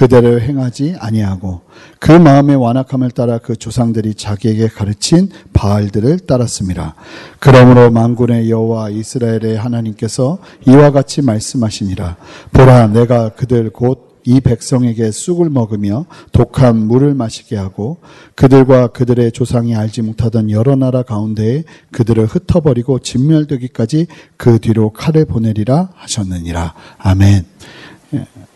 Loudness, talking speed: -12 LUFS, 315 characters per minute